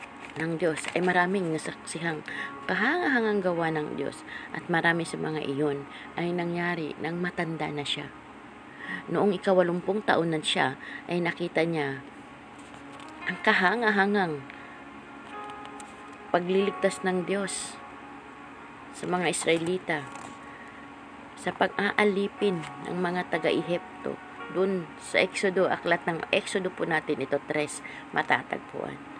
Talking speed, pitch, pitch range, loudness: 110 wpm, 175 Hz, 155-190 Hz, -28 LUFS